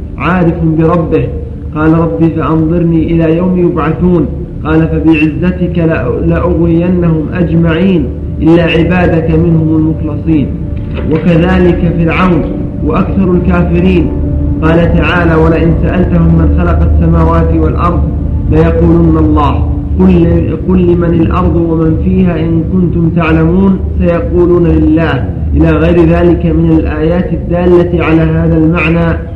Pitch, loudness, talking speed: 160 Hz, -9 LUFS, 105 wpm